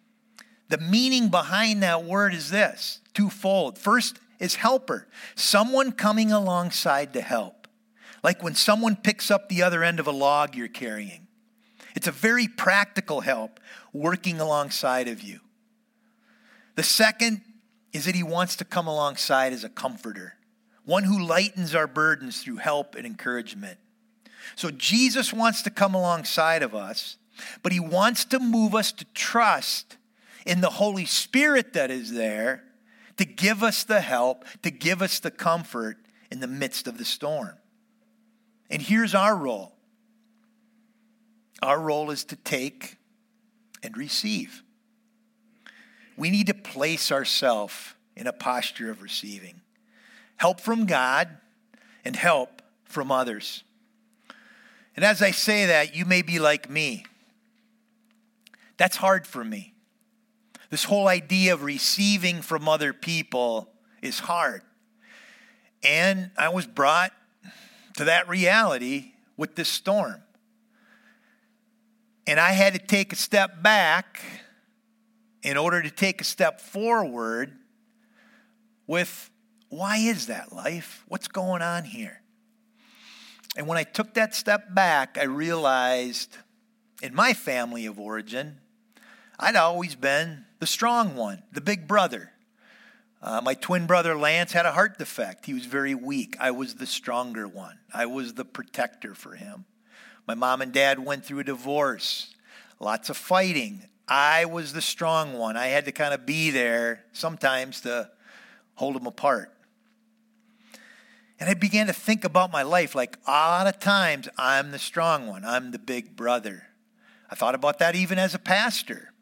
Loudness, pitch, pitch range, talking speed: -24 LUFS, 205 Hz, 165-225 Hz, 145 wpm